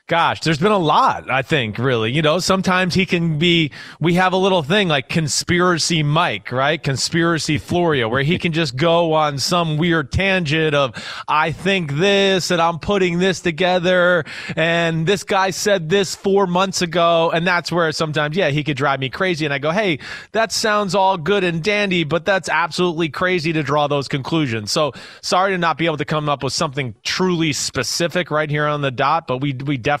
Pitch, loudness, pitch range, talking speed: 165 Hz, -18 LUFS, 150-185 Hz, 200 wpm